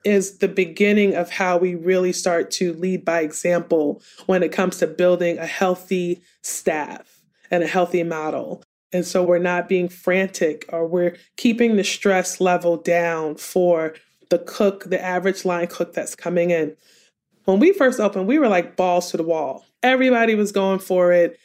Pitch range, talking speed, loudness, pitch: 175-190 Hz, 175 wpm, -20 LUFS, 180 Hz